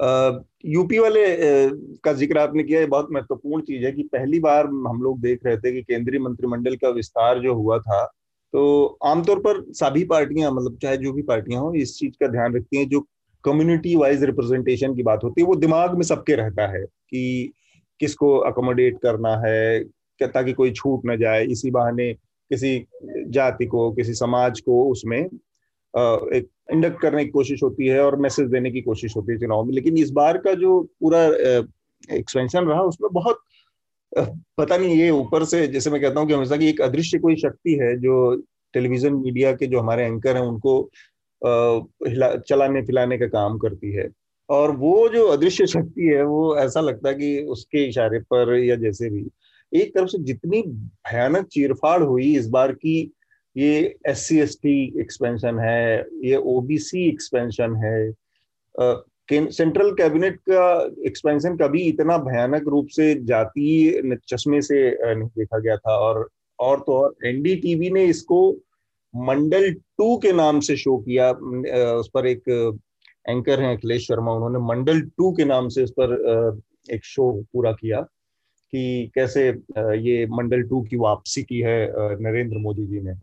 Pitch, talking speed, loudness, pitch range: 135 Hz, 175 wpm, -20 LUFS, 120-155 Hz